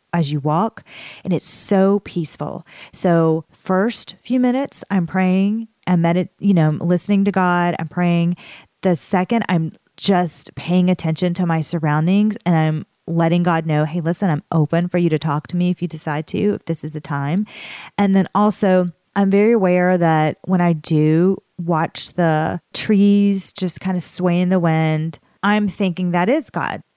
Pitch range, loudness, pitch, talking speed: 160-195 Hz, -18 LUFS, 180 Hz, 180 wpm